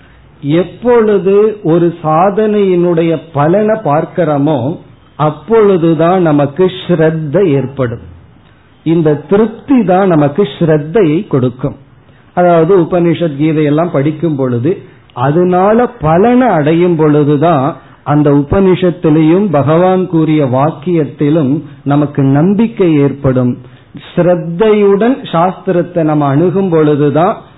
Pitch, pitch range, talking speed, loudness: 160 Hz, 145-180 Hz, 80 wpm, -10 LUFS